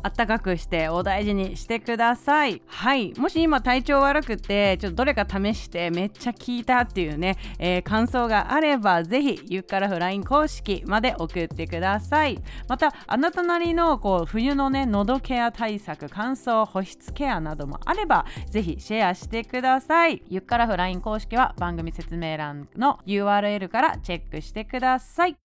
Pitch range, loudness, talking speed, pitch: 185-265 Hz, -24 LUFS, 355 characters per minute, 220 Hz